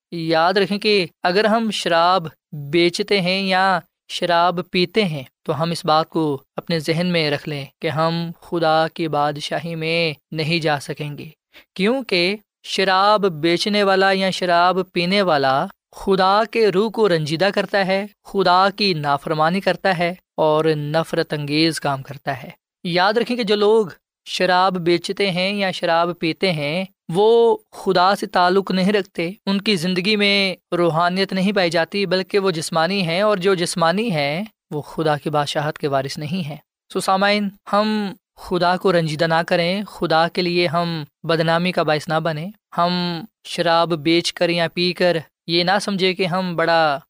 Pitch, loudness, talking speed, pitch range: 175 Hz, -19 LUFS, 165 wpm, 165-195 Hz